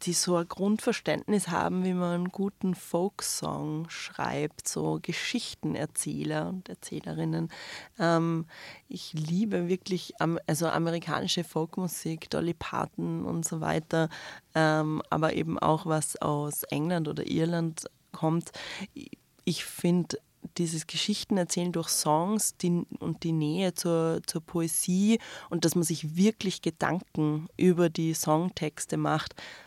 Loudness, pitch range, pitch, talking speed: -30 LUFS, 155-180 Hz, 165 Hz, 115 wpm